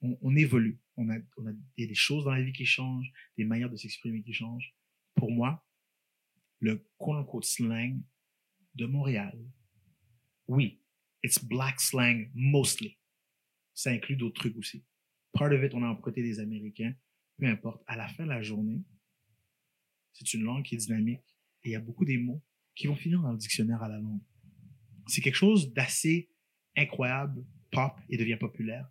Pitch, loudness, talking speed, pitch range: 120 Hz, -31 LUFS, 170 wpm, 110-135 Hz